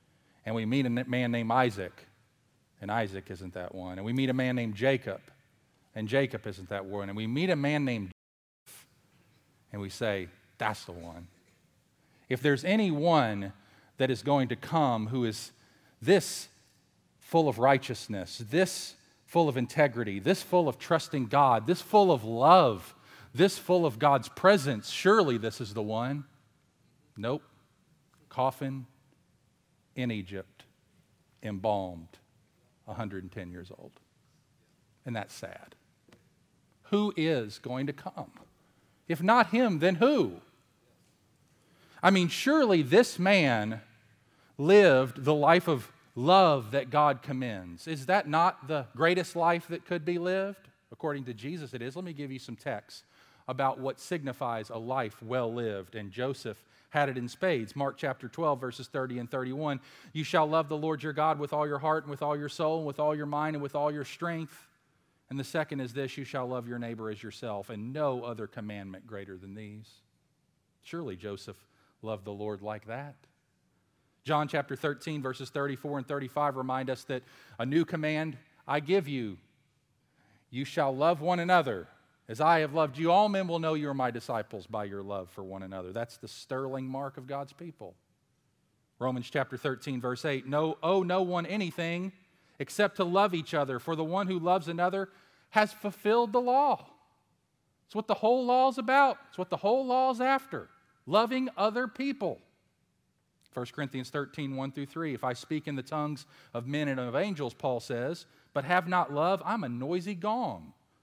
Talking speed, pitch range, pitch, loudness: 170 wpm, 115-165 Hz, 140 Hz, -30 LUFS